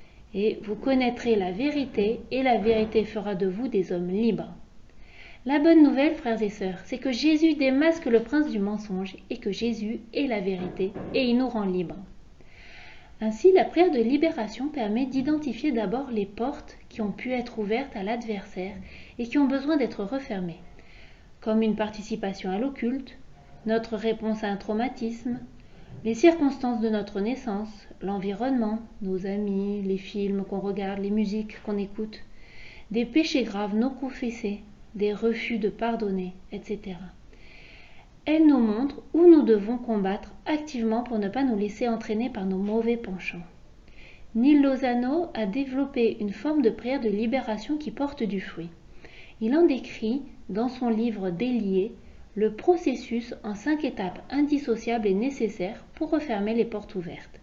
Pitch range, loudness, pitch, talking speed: 205-260 Hz, -26 LUFS, 225 Hz, 155 wpm